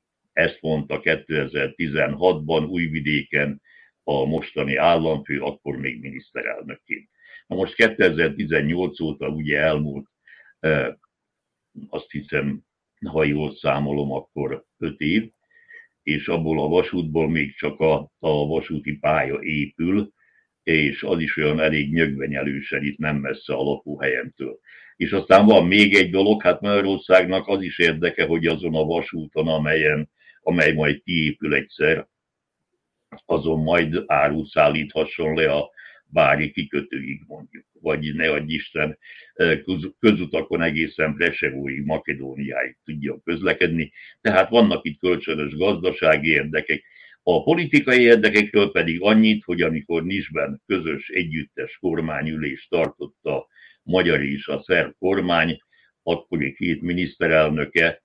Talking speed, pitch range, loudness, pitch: 115 wpm, 75-90 Hz, -21 LUFS, 80 Hz